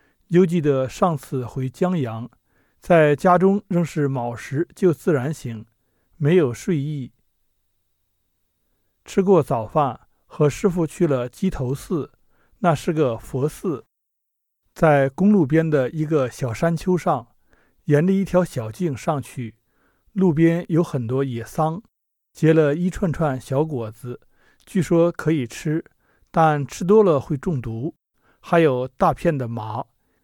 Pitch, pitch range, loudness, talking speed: 150 Hz, 125-175 Hz, -21 LUFS, 185 characters per minute